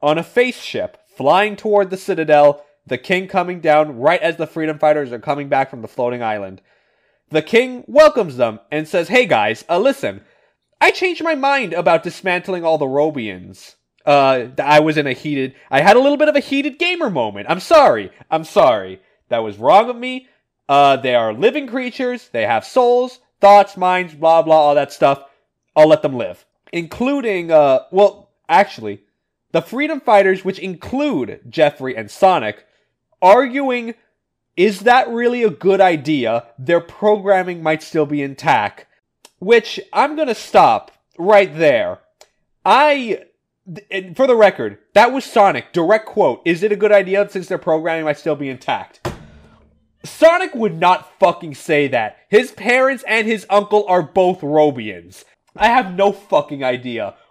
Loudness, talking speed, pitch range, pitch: -15 LUFS, 165 wpm, 150-235 Hz, 180 Hz